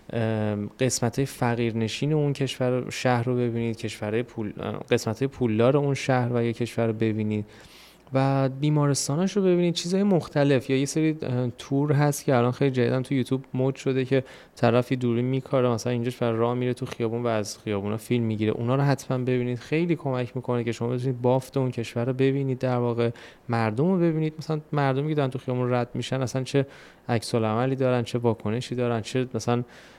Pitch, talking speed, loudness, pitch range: 125 Hz, 185 wpm, -25 LUFS, 120-135 Hz